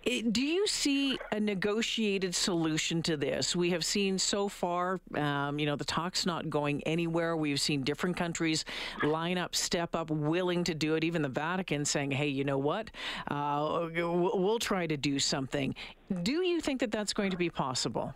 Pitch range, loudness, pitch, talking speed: 150-200 Hz, -31 LUFS, 170 Hz, 185 wpm